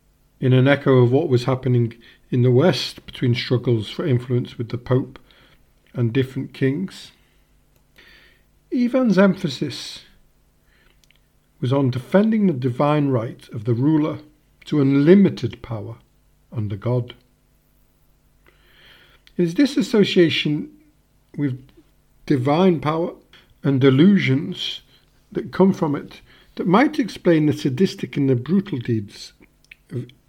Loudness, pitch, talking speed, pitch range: -20 LUFS, 140 Hz, 115 wpm, 125-175 Hz